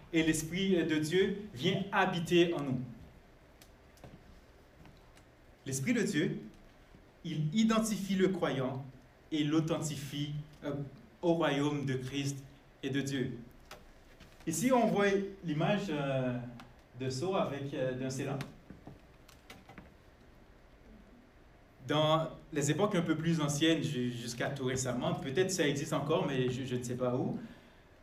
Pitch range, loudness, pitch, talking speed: 130-165 Hz, -33 LUFS, 145 Hz, 120 wpm